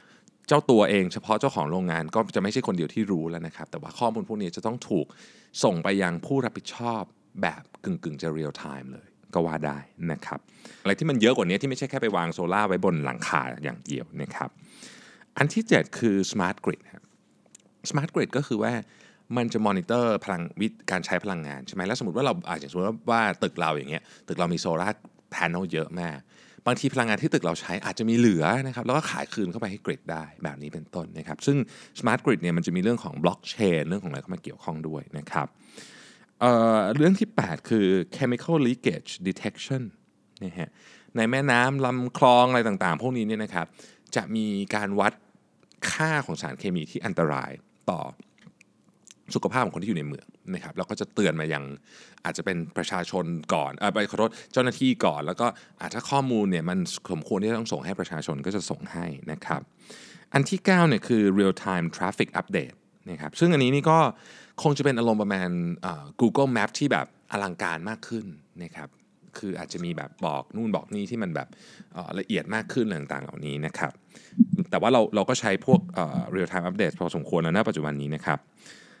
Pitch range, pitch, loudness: 85-130 Hz, 110 Hz, -26 LUFS